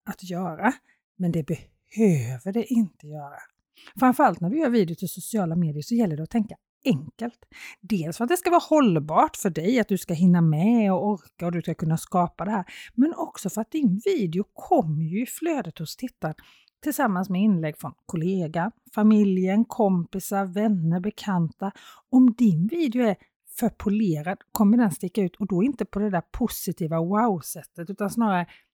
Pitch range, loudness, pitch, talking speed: 170-230 Hz, -24 LUFS, 195 Hz, 180 wpm